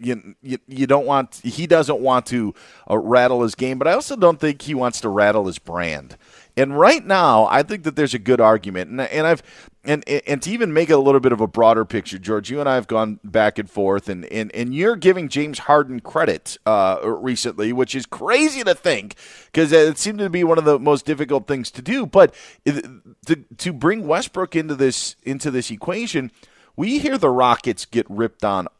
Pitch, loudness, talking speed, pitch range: 130 Hz, -19 LUFS, 215 wpm, 110-155 Hz